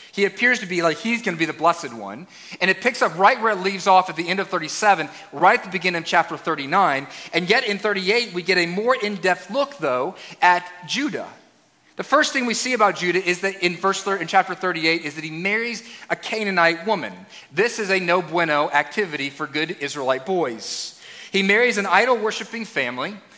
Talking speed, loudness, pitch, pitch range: 210 wpm, -20 LUFS, 190 Hz, 170-215 Hz